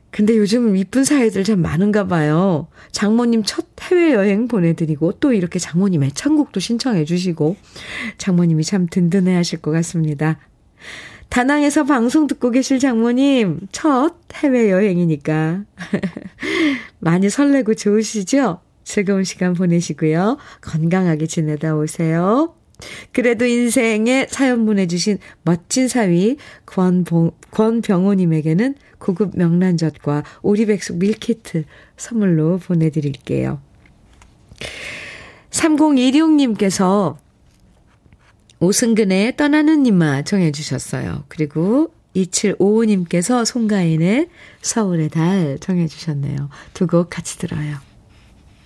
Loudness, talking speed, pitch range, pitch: -17 LUFS, 250 characters per minute, 165-235 Hz, 190 Hz